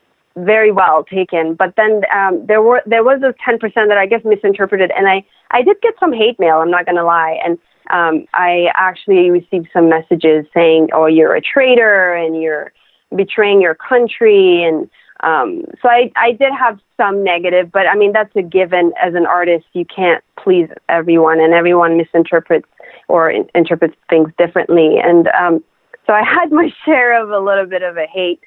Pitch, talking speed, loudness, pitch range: 185 Hz, 190 wpm, -12 LUFS, 170-220 Hz